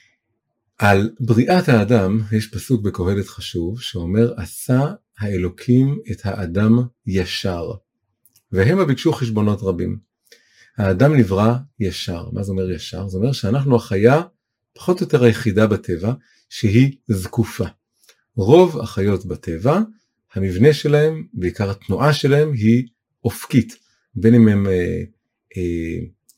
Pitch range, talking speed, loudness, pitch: 100-125 Hz, 115 wpm, -18 LUFS, 115 Hz